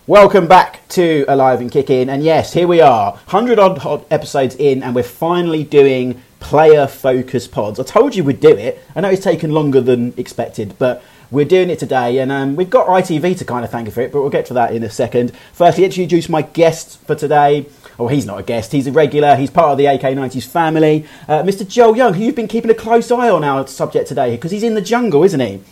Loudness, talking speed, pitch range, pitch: -13 LUFS, 245 wpm, 130-185 Hz, 150 Hz